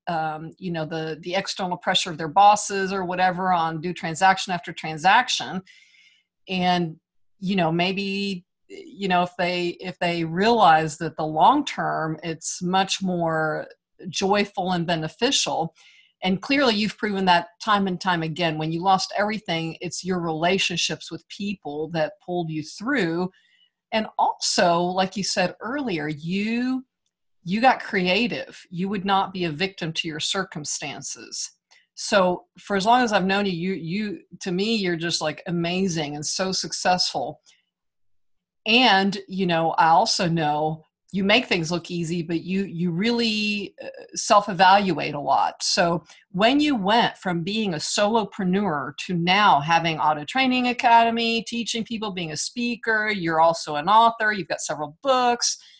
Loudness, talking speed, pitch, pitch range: -22 LUFS, 155 wpm, 185 Hz, 165-210 Hz